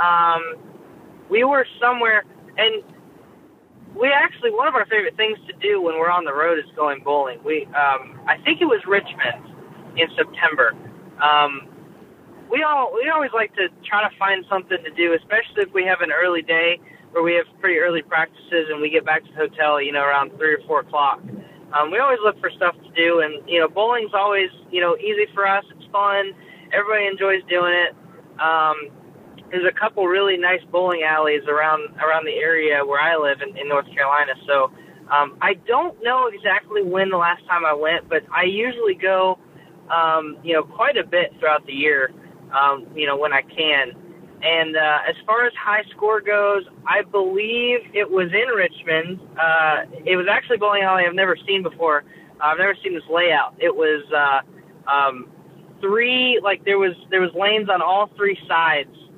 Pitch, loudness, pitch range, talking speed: 180 Hz, -19 LUFS, 160-205 Hz, 195 wpm